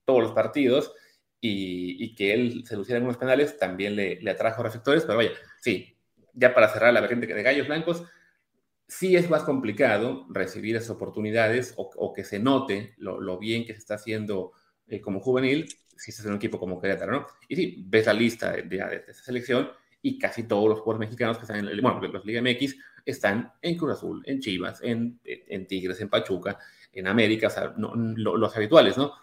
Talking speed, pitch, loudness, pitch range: 210 wpm, 115 Hz, -26 LUFS, 105-130 Hz